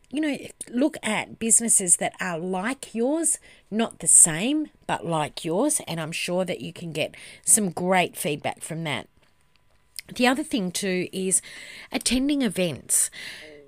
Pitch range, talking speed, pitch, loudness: 170-255 Hz, 150 wpm, 195 Hz, -23 LUFS